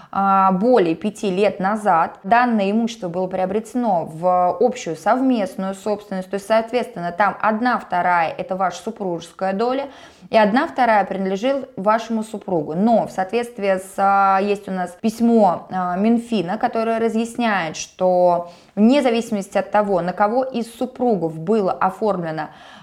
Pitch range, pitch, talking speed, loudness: 185-225 Hz, 205 Hz, 130 wpm, -19 LUFS